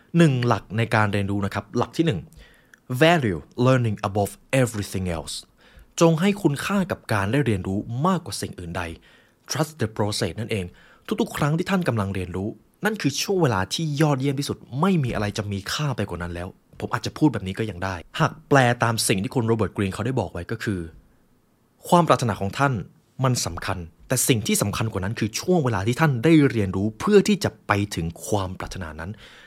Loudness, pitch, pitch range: -23 LUFS, 115 Hz, 100-145 Hz